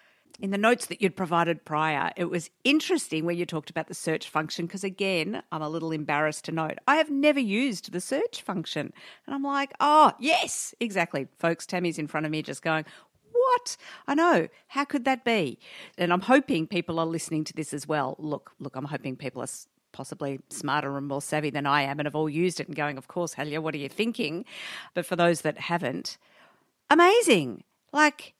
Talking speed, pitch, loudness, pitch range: 205 wpm, 170 Hz, -27 LUFS, 155-245 Hz